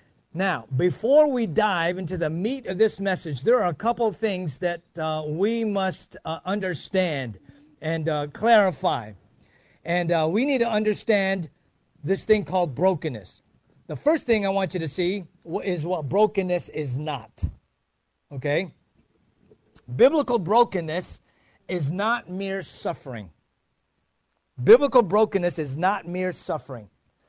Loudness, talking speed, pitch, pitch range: -24 LUFS, 135 wpm, 180 Hz, 155-210 Hz